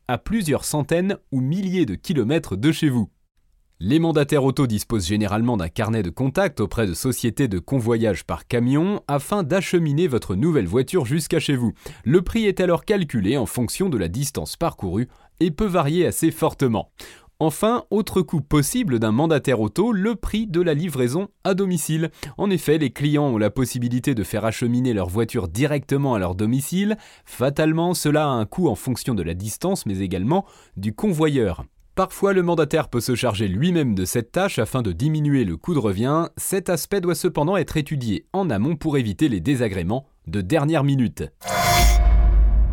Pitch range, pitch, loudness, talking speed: 110-170 Hz, 140 Hz, -22 LUFS, 175 wpm